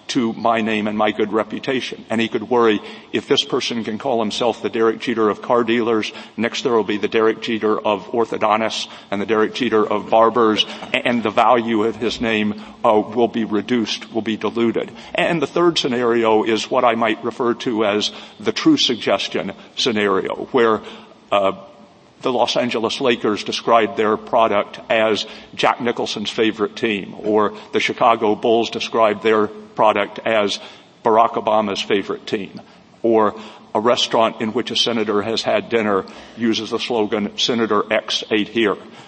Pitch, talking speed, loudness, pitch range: 110 Hz, 165 wpm, -19 LUFS, 105-115 Hz